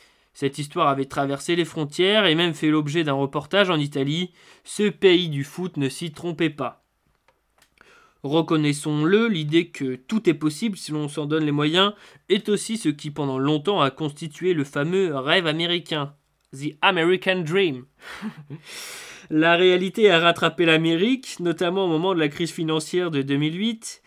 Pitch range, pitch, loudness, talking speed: 150-185 Hz, 165 Hz, -22 LUFS, 155 wpm